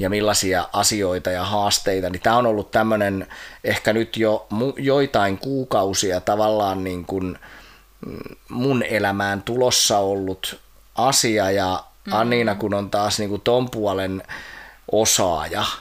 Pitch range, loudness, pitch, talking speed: 95-110 Hz, -20 LUFS, 105 Hz, 130 wpm